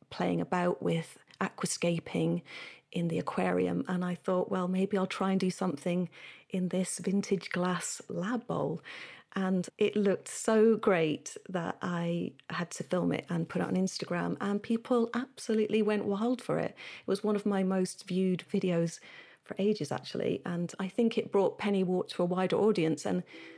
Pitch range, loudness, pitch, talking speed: 175-205 Hz, -32 LUFS, 185 Hz, 175 wpm